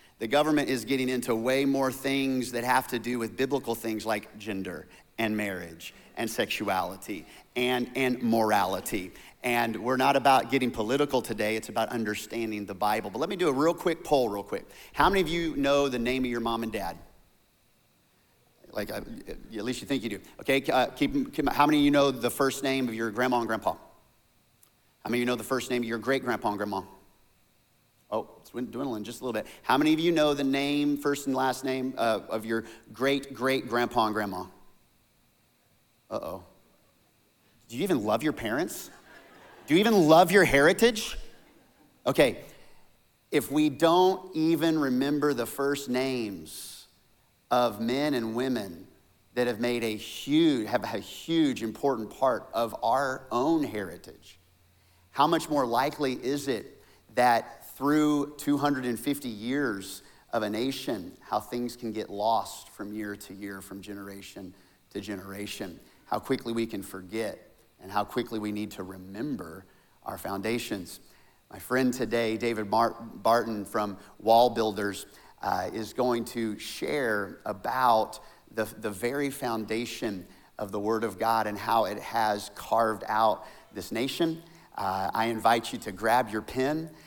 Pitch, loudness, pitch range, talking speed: 120 Hz, -28 LUFS, 105-135 Hz, 165 wpm